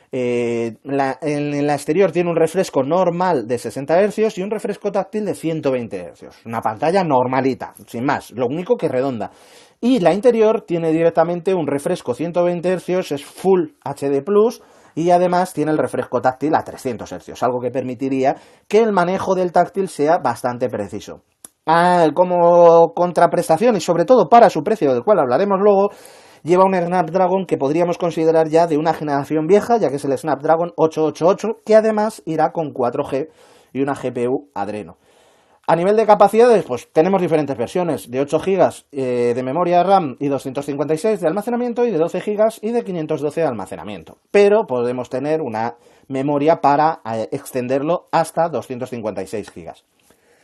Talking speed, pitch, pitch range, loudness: 165 wpm, 160 Hz, 135-190 Hz, -18 LUFS